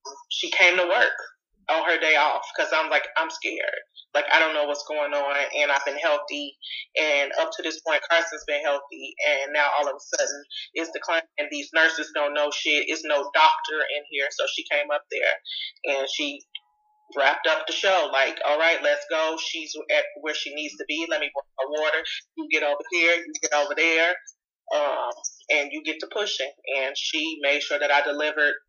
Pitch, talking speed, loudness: 160 Hz, 205 wpm, -23 LUFS